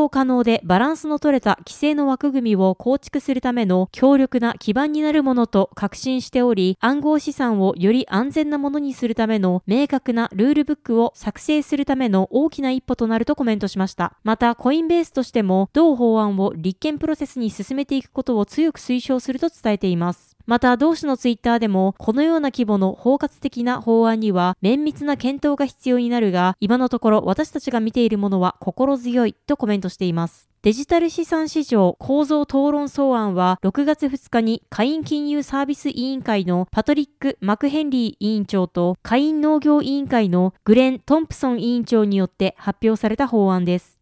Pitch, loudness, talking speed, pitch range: 245 Hz, -20 LUFS, 385 characters per minute, 210-285 Hz